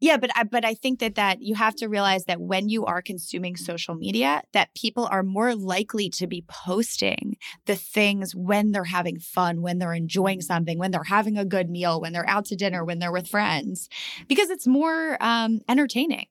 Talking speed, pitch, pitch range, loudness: 210 wpm, 200 Hz, 180-230 Hz, -24 LUFS